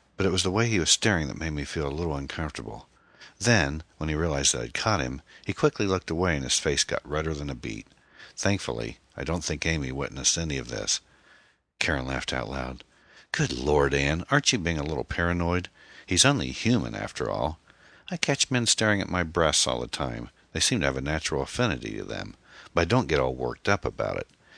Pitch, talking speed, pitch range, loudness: 80 Hz, 220 wpm, 70-95 Hz, -26 LUFS